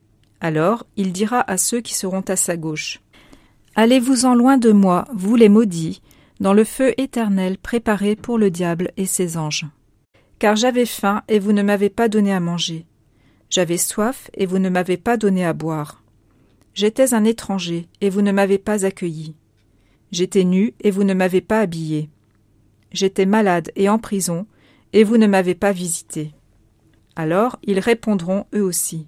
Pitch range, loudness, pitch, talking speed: 160-215 Hz, -18 LUFS, 190 Hz, 170 wpm